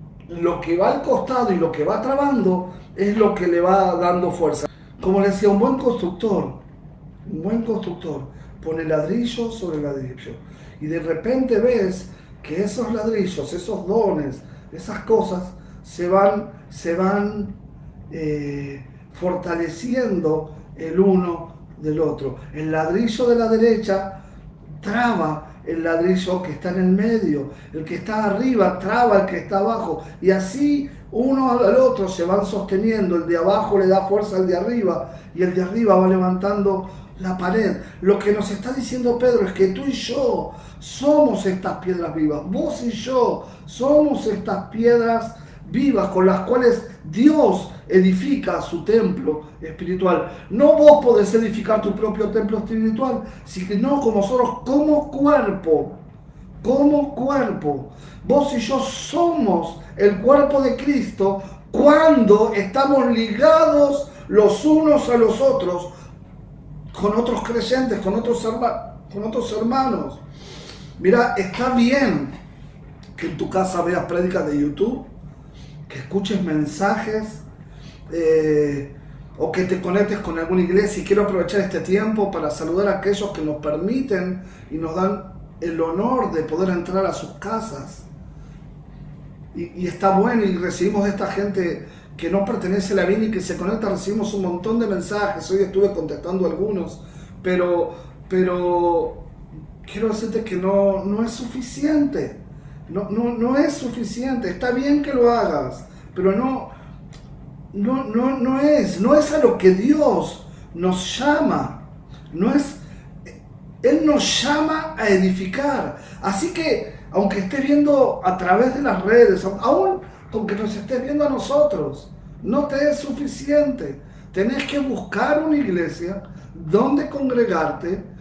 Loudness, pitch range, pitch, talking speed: -20 LUFS, 165-235 Hz, 195 Hz, 145 wpm